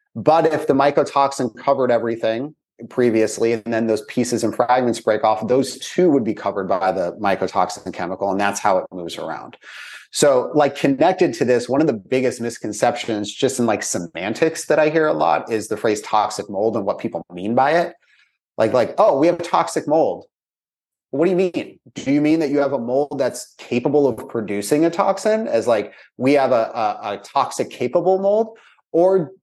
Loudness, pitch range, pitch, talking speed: -19 LUFS, 115-155 Hz, 130 Hz, 200 wpm